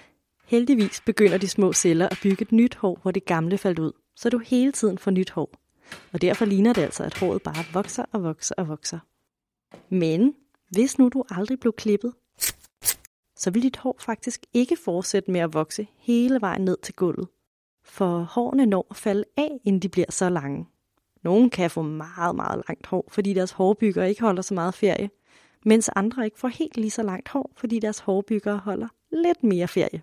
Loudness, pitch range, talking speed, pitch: -24 LUFS, 185-235 Hz, 200 wpm, 205 Hz